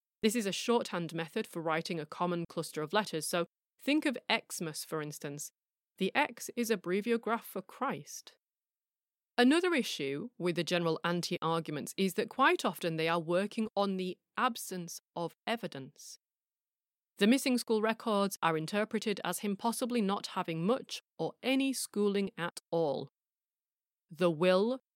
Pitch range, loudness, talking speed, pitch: 170-225 Hz, -33 LUFS, 150 wpm, 190 Hz